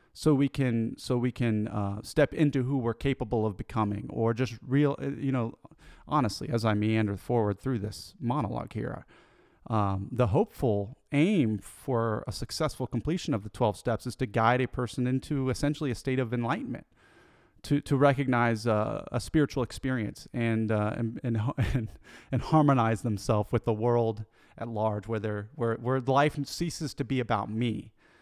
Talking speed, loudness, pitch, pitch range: 170 wpm, -29 LUFS, 120 Hz, 110-135 Hz